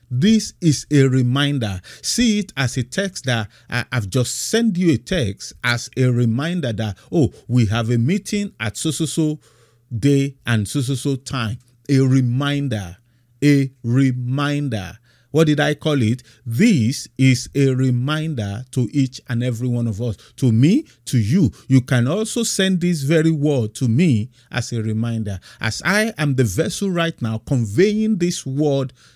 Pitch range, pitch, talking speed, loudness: 120-150 Hz, 130 Hz, 160 wpm, -19 LUFS